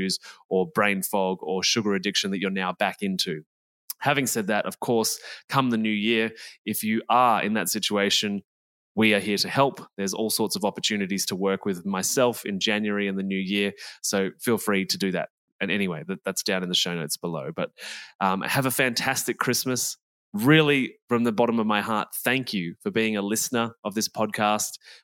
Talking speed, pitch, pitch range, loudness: 200 wpm, 105 Hz, 100-115 Hz, -25 LUFS